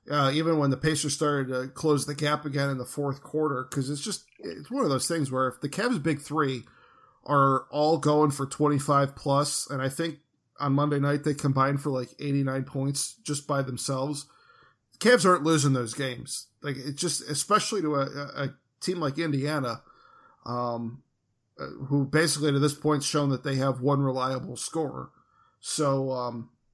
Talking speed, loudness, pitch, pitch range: 185 wpm, -27 LUFS, 140 Hz, 135-150 Hz